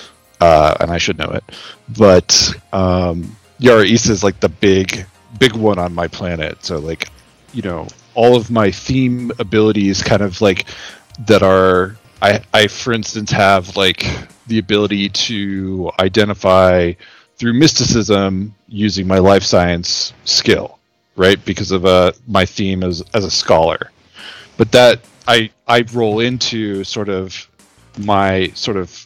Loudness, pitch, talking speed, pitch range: -14 LUFS, 100 Hz, 145 wpm, 95-115 Hz